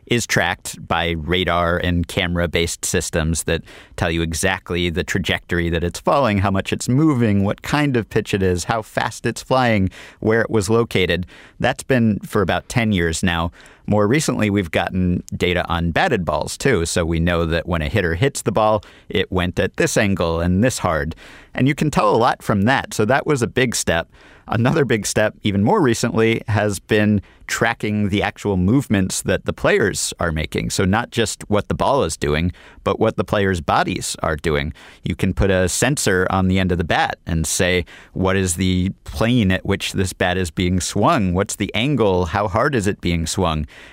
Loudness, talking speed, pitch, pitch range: -19 LUFS, 200 wpm, 95 Hz, 85-110 Hz